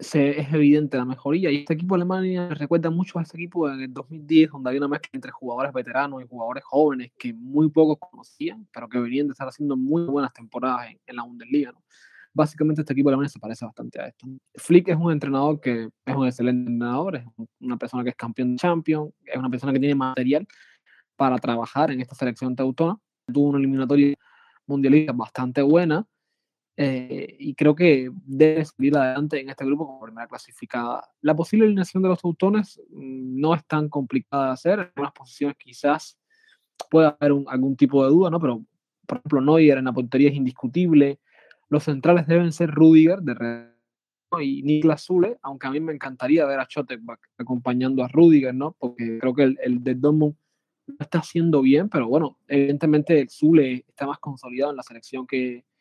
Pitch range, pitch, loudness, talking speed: 130-160 Hz, 145 Hz, -22 LUFS, 195 wpm